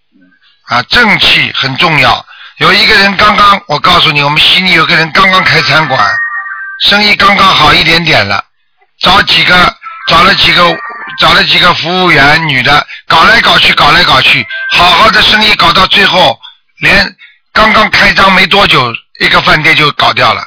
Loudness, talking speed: -4 LUFS, 250 characters per minute